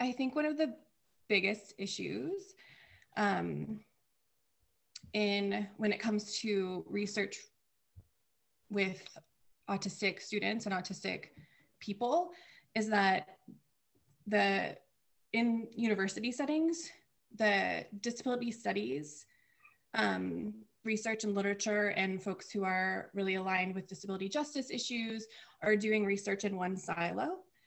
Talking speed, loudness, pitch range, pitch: 105 wpm, -35 LUFS, 190-230 Hz, 205 Hz